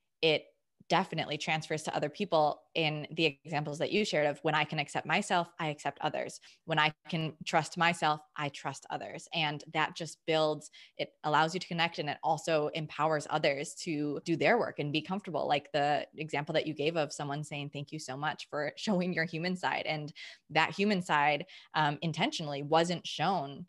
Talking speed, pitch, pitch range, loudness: 195 wpm, 155 Hz, 150-170 Hz, -32 LUFS